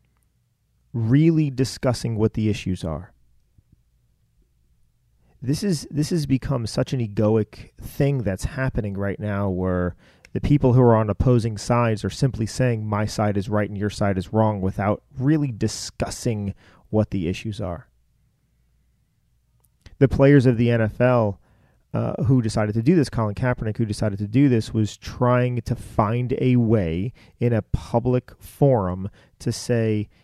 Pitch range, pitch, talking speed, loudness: 100-125 Hz, 110 Hz, 150 wpm, -22 LUFS